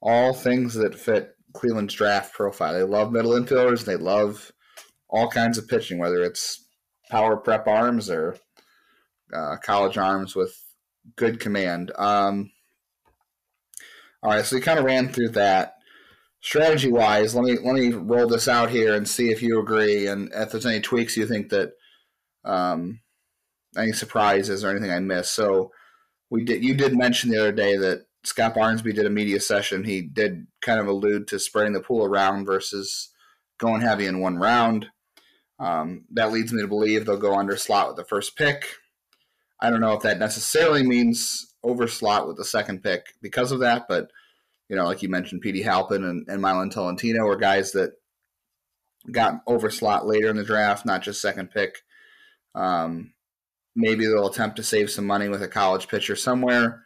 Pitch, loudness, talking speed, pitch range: 110 Hz, -23 LUFS, 175 wpm, 100-120 Hz